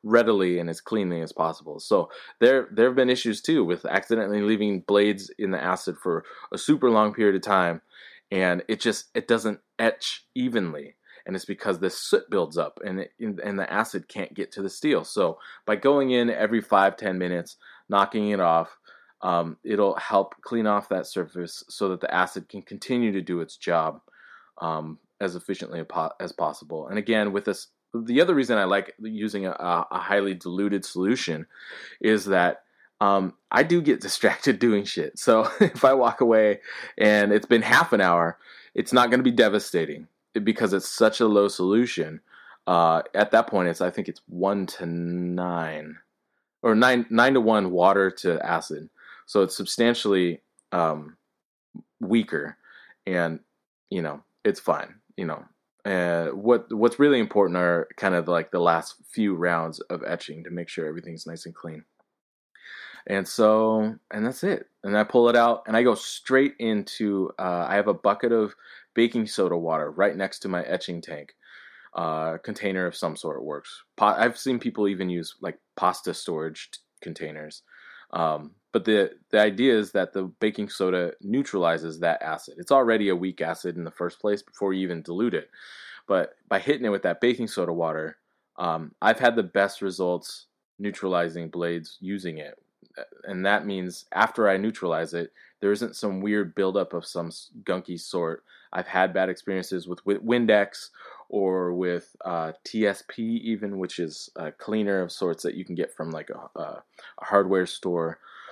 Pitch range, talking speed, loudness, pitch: 85-110 Hz, 180 wpm, -24 LUFS, 100 Hz